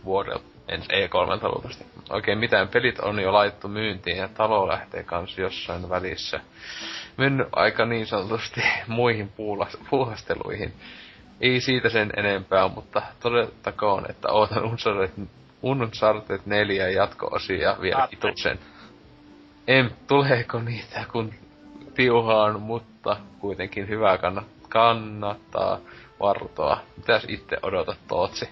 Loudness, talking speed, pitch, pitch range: -24 LUFS, 110 wpm, 110 Hz, 100-120 Hz